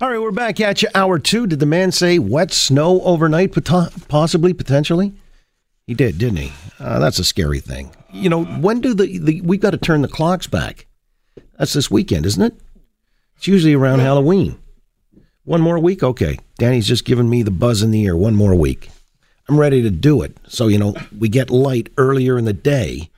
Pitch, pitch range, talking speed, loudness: 145 Hz, 115-180 Hz, 205 wpm, -16 LUFS